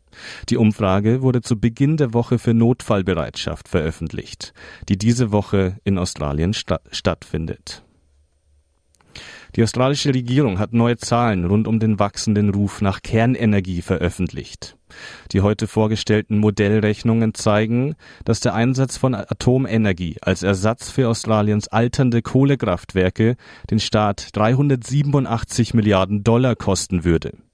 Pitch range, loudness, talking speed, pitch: 95-120 Hz, -19 LUFS, 115 wpm, 110 Hz